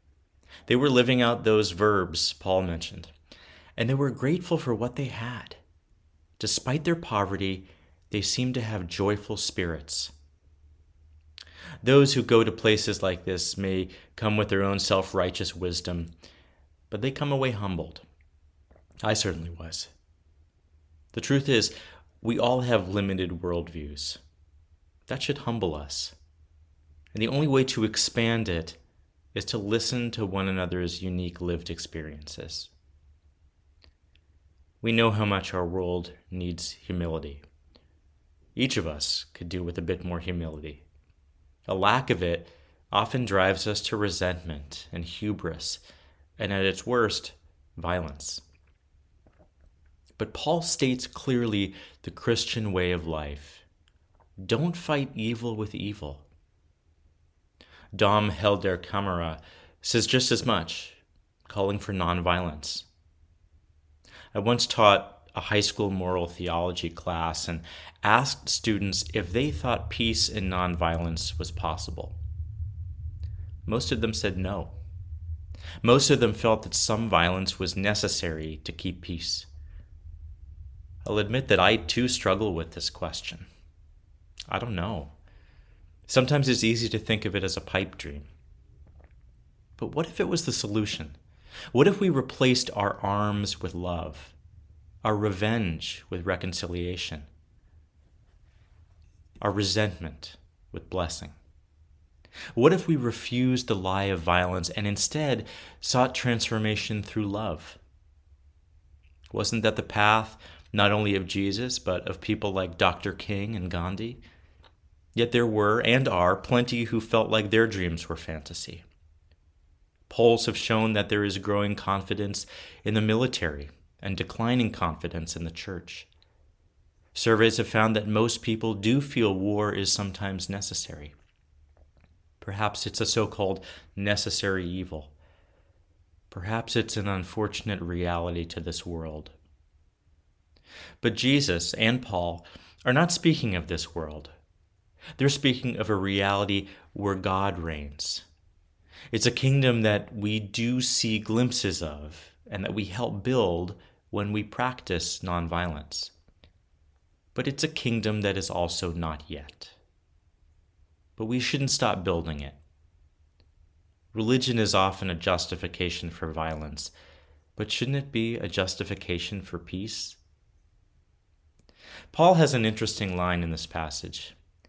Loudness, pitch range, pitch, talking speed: -27 LUFS, 80-105 Hz, 90 Hz, 130 wpm